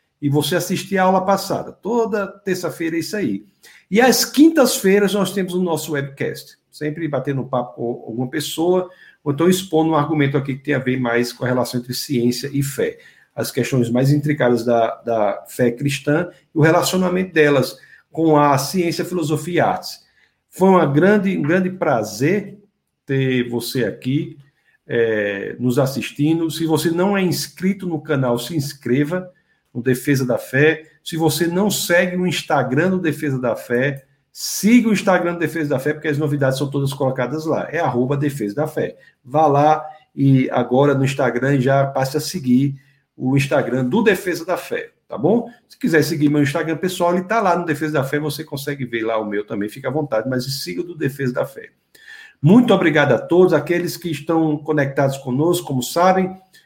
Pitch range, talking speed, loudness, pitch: 135-175 Hz, 185 wpm, -19 LUFS, 150 Hz